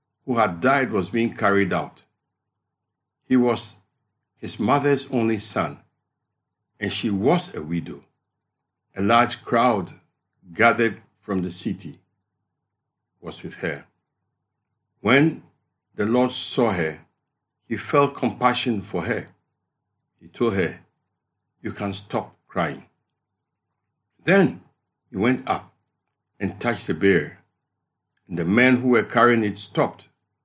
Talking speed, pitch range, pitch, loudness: 120 wpm, 100-125 Hz, 115 Hz, -22 LUFS